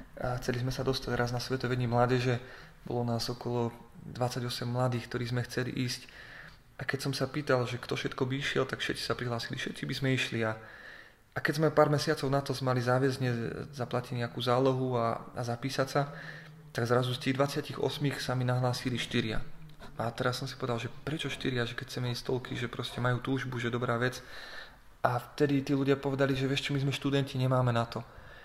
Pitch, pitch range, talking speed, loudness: 125 Hz, 120-140 Hz, 200 wpm, -32 LUFS